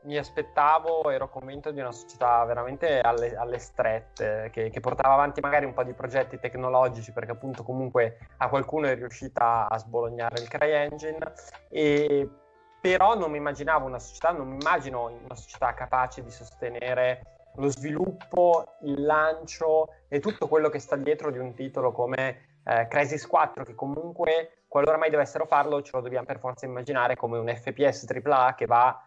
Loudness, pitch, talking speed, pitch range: -27 LUFS, 135 Hz, 170 wpm, 125-150 Hz